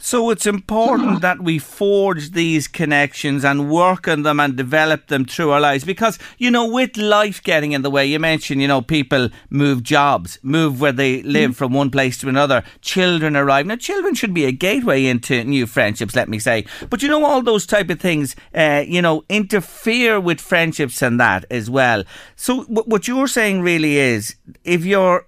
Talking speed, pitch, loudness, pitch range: 195 wpm, 160 Hz, -17 LUFS, 140-210 Hz